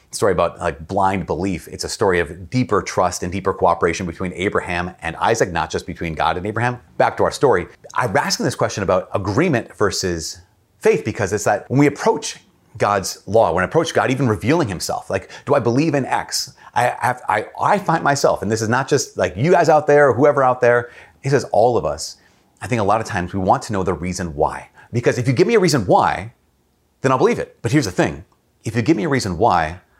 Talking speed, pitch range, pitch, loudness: 240 wpm, 90-125 Hz, 105 Hz, -19 LUFS